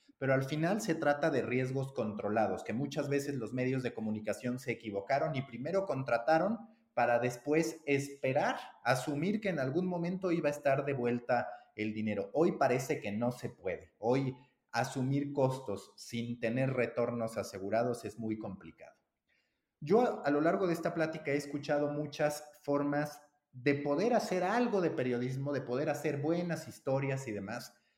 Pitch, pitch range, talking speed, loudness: 135 Hz, 120-150 Hz, 160 wpm, -34 LUFS